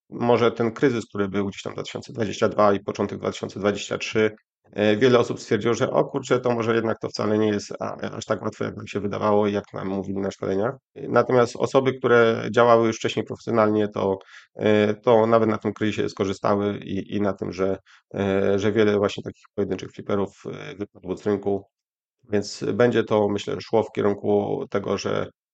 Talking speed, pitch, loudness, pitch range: 170 wpm, 105 Hz, -23 LUFS, 100-115 Hz